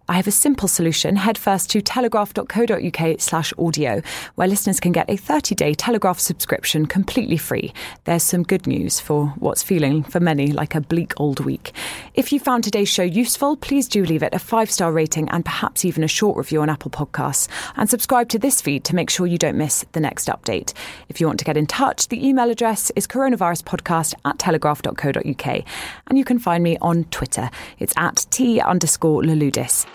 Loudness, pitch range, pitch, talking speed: -19 LUFS, 160-225 Hz, 180 Hz, 200 wpm